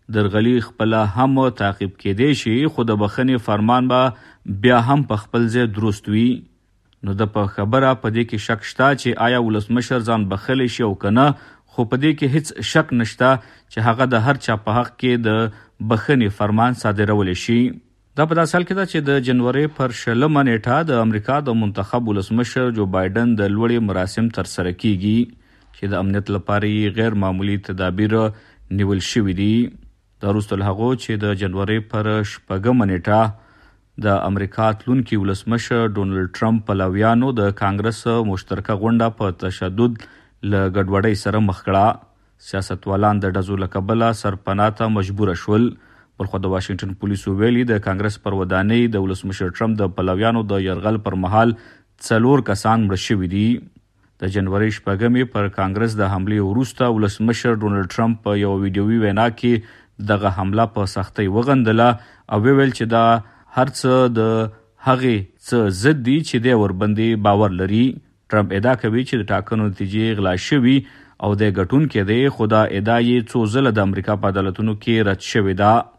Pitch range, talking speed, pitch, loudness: 100-120 Hz, 165 wpm, 110 Hz, -19 LUFS